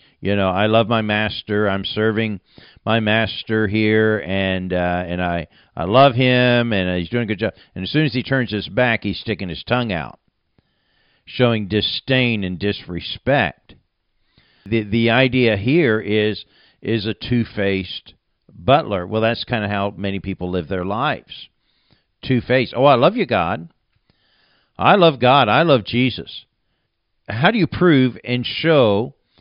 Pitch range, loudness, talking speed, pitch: 100-120 Hz, -18 LUFS, 165 wpm, 110 Hz